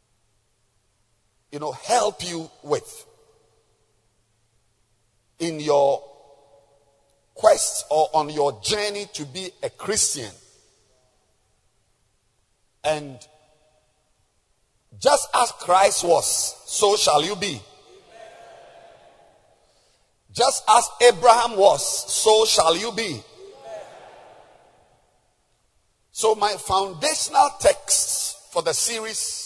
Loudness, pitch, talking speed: -20 LUFS, 150 Hz, 80 wpm